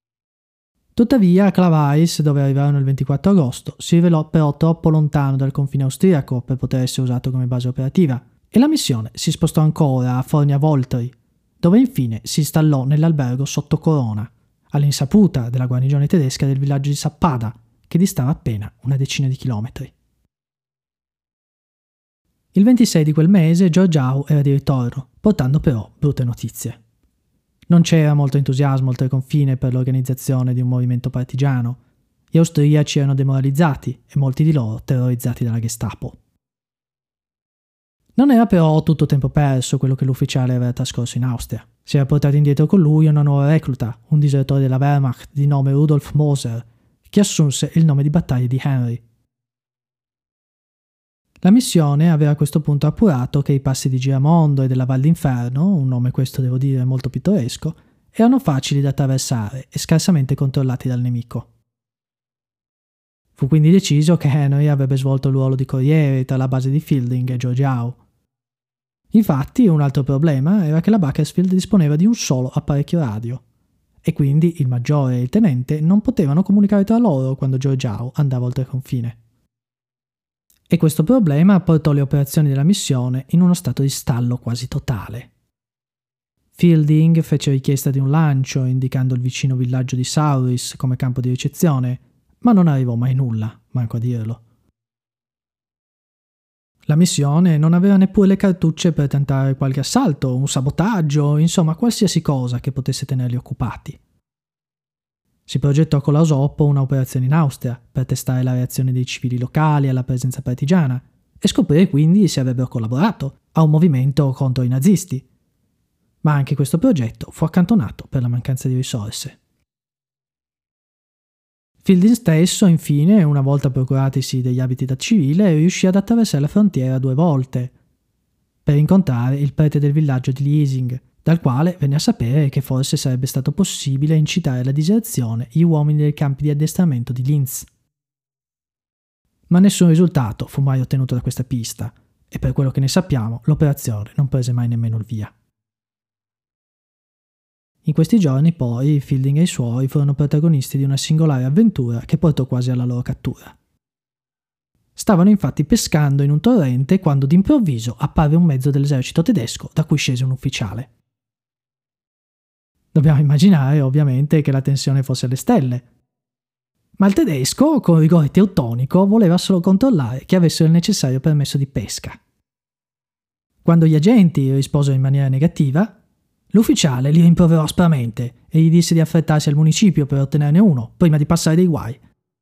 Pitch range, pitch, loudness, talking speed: 125-160 Hz, 140 Hz, -17 LUFS, 155 wpm